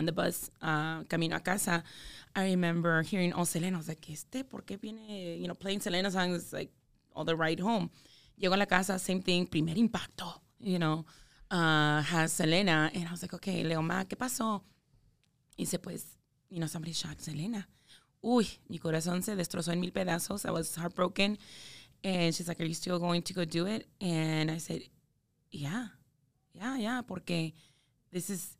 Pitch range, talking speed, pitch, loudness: 160-190 Hz, 190 wpm, 175 Hz, -33 LUFS